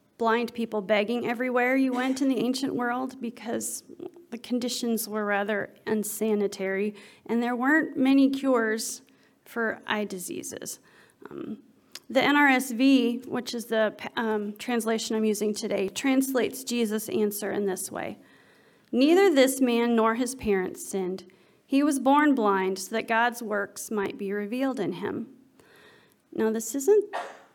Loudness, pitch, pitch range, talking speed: -26 LUFS, 230 Hz, 210-260 Hz, 140 wpm